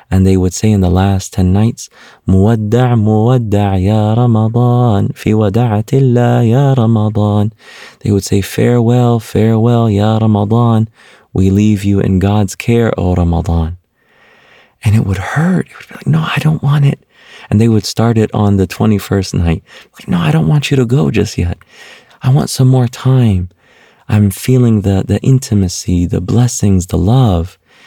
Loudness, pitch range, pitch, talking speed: -12 LUFS, 100-120 Hz, 110 Hz, 170 wpm